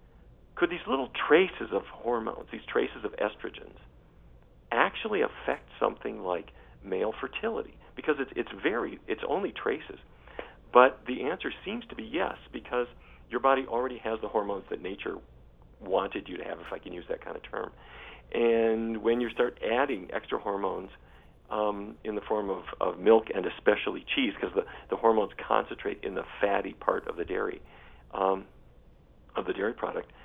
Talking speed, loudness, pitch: 170 wpm, -30 LUFS, 120 Hz